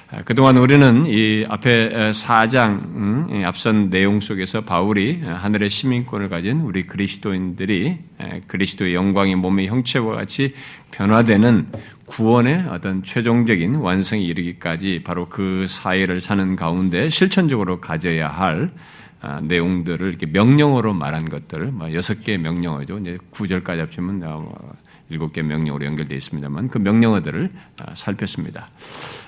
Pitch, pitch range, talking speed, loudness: 100 Hz, 90-115 Hz, 315 characters per minute, -19 LUFS